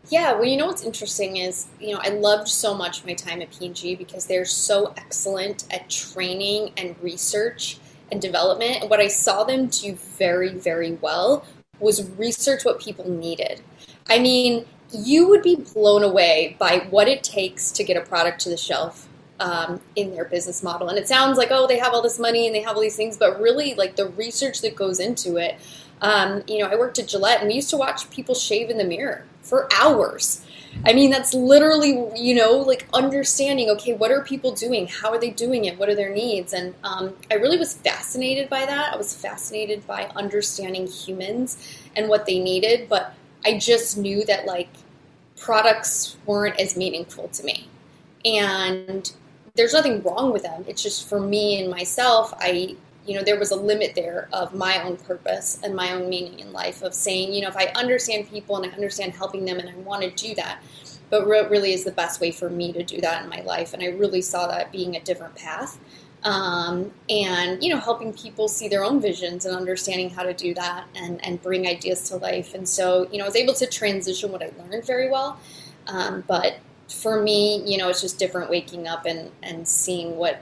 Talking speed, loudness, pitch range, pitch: 210 wpm, -22 LUFS, 180-225 Hz, 200 Hz